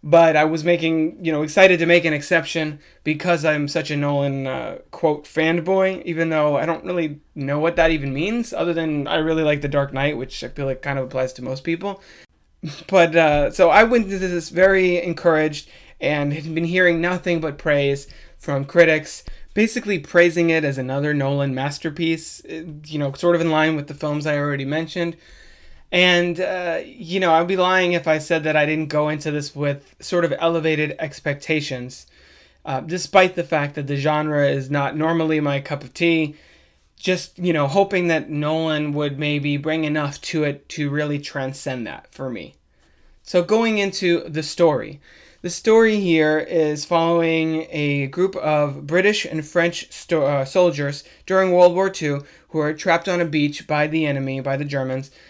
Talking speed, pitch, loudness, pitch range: 185 wpm, 155 Hz, -20 LUFS, 145-170 Hz